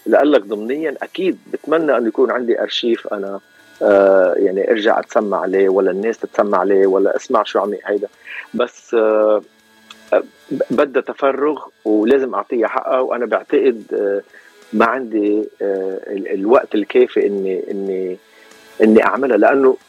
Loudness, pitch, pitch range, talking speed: -16 LUFS, 110 Hz, 100-150 Hz, 120 wpm